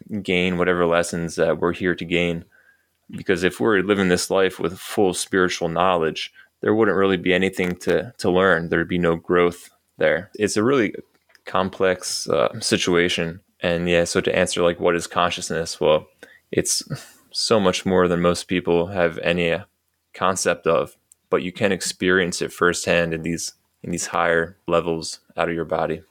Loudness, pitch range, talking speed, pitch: -21 LUFS, 85-90 Hz, 170 wpm, 85 Hz